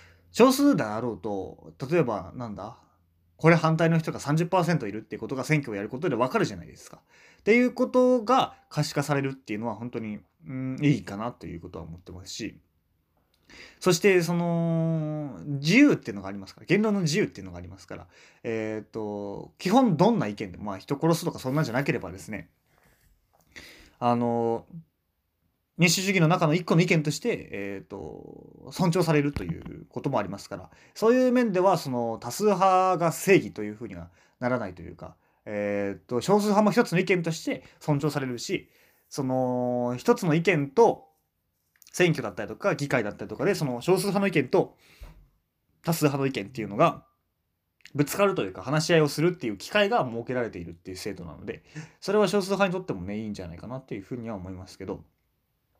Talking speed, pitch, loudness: 390 characters per minute, 130 Hz, -26 LUFS